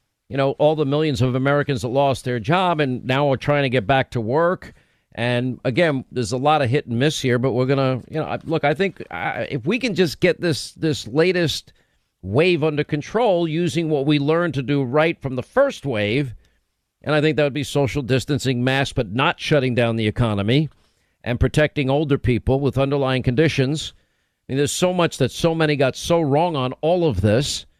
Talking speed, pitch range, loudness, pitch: 210 wpm, 125-155 Hz, -20 LUFS, 140 Hz